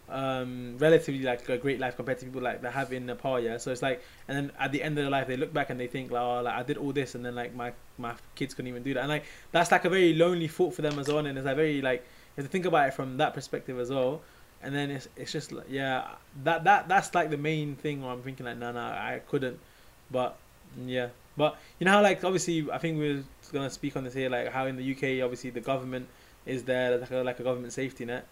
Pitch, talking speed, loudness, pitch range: 135 Hz, 280 wpm, -30 LUFS, 125-150 Hz